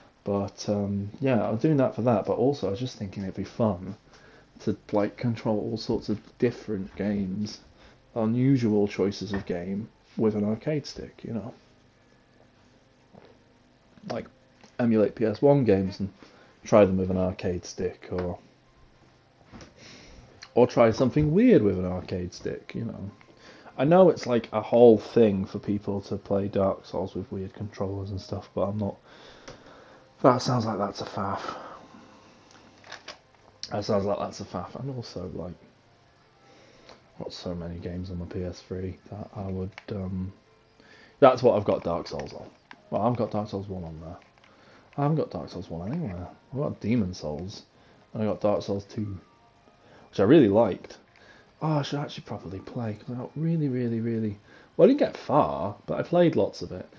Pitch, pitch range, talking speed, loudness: 105 Hz, 95-120 Hz, 170 wpm, -27 LUFS